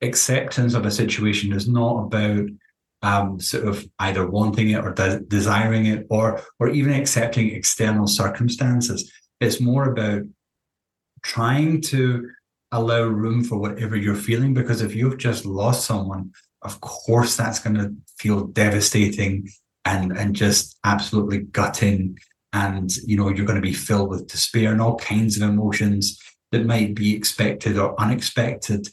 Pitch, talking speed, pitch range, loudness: 105 Hz, 150 wpm, 100-115 Hz, -21 LUFS